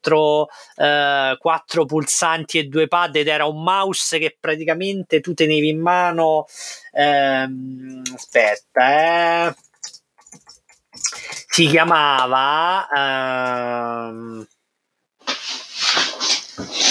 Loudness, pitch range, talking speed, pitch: -18 LUFS, 130-165 Hz, 80 wpm, 155 Hz